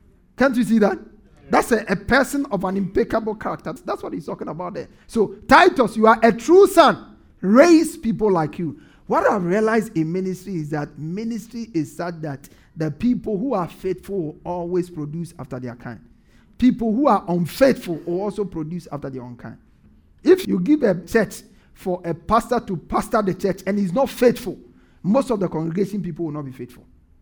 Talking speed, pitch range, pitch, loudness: 190 wpm, 165-230 Hz, 195 Hz, -20 LUFS